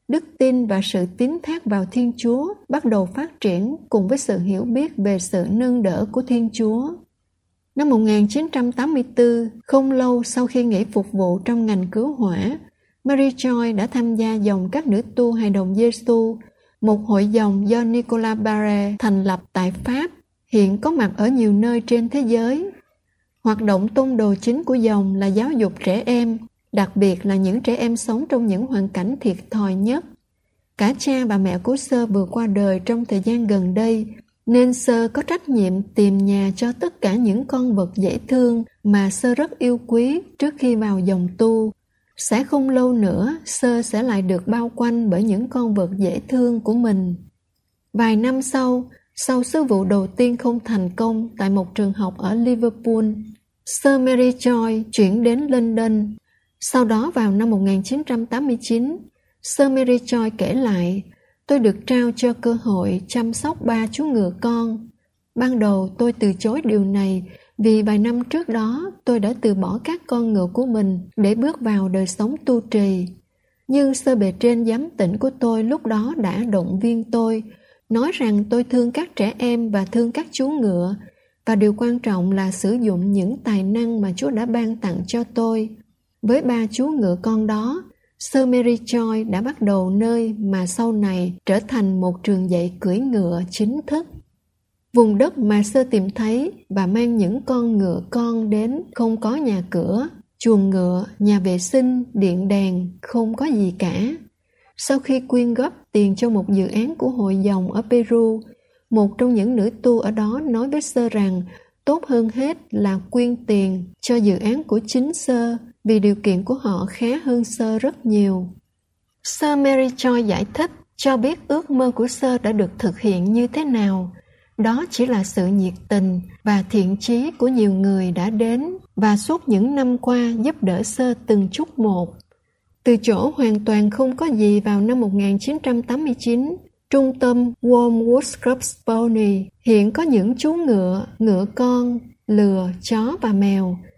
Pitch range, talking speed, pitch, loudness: 200-250 Hz, 185 wpm, 225 Hz, -19 LUFS